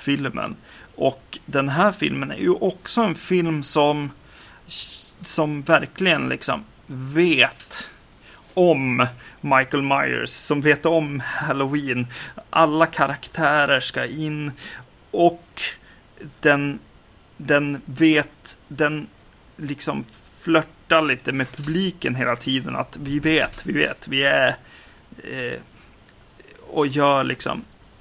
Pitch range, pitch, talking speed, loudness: 140-160 Hz, 145 Hz, 105 wpm, -21 LUFS